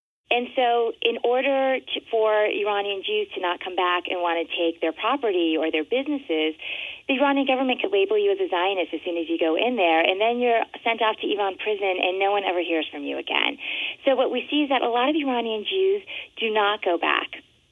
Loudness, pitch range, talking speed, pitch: -23 LUFS, 180-270 Hz, 230 wpm, 220 Hz